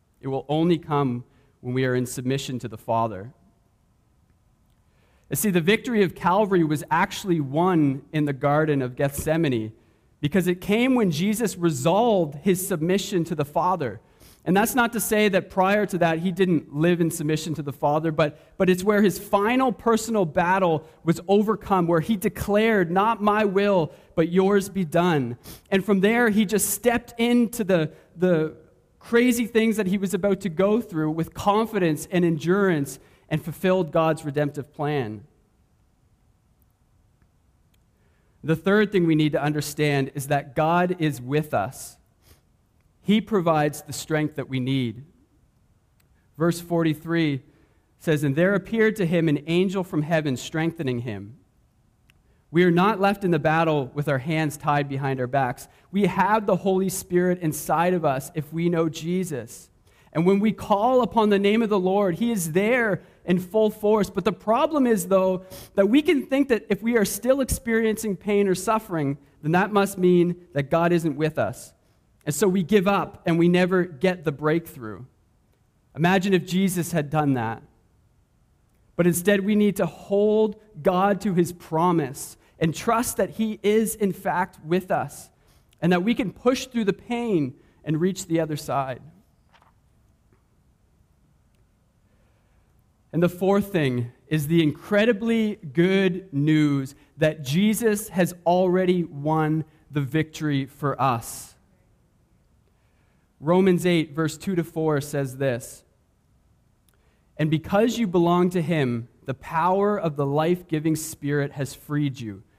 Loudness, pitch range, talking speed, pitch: -23 LUFS, 145-195 Hz, 155 wpm, 170 Hz